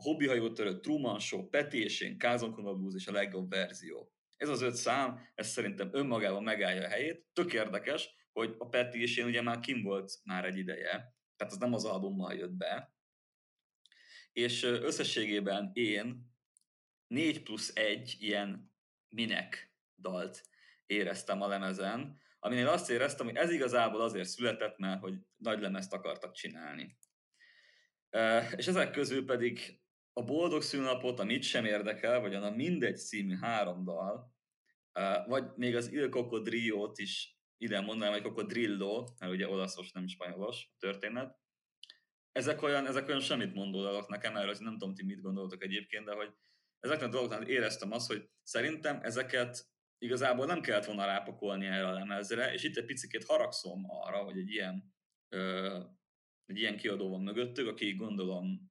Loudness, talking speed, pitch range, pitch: -36 LUFS, 155 wpm, 95-125 Hz, 105 Hz